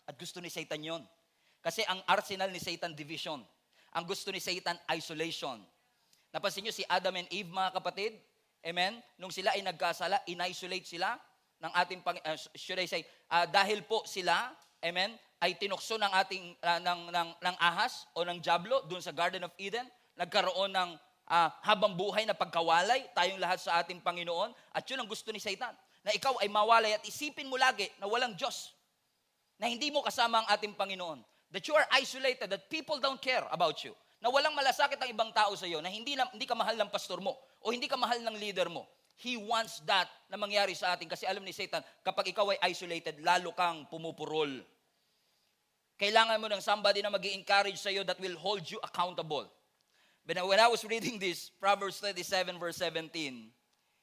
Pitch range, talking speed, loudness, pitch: 175-215 Hz, 190 wpm, -33 LUFS, 190 Hz